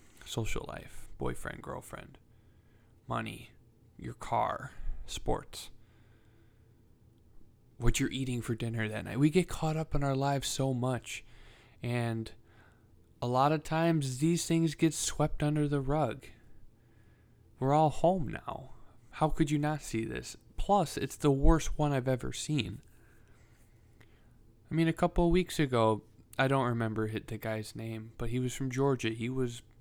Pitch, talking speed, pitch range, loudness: 120 Hz, 150 wpm, 110-150 Hz, -32 LUFS